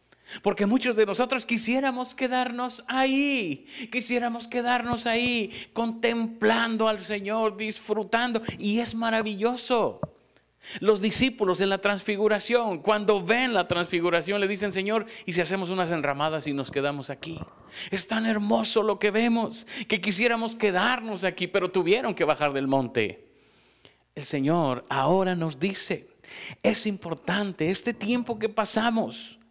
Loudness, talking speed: -26 LUFS, 130 wpm